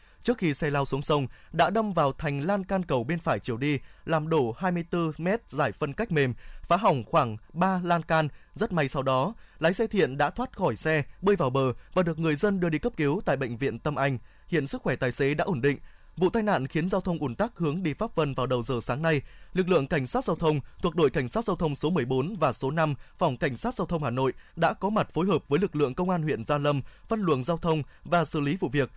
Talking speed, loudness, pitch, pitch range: 265 wpm, -27 LUFS, 155 Hz, 140-180 Hz